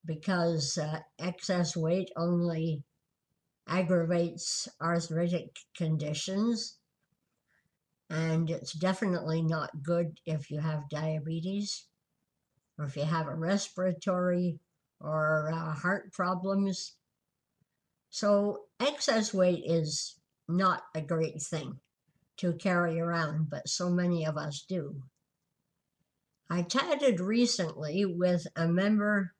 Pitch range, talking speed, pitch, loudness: 155-185 Hz, 100 wpm, 170 Hz, -31 LUFS